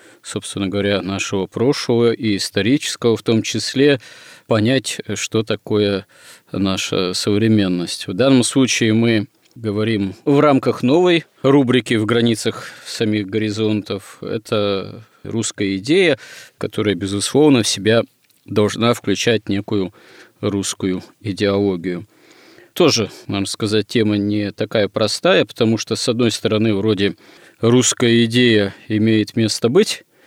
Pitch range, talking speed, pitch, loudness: 100-115 Hz, 115 wpm, 110 Hz, -17 LUFS